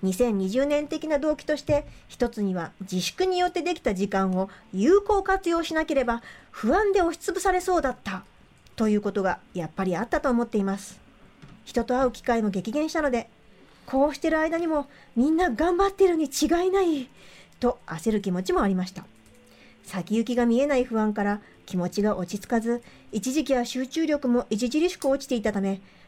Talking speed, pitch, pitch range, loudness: 355 characters per minute, 245 Hz, 205-310 Hz, -25 LUFS